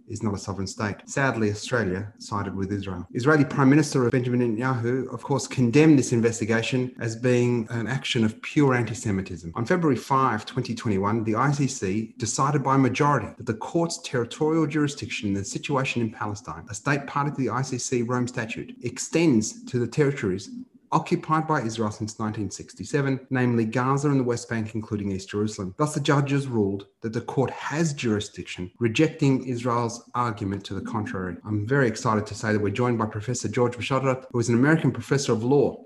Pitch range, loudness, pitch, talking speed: 110-135 Hz, -25 LUFS, 120 Hz, 180 wpm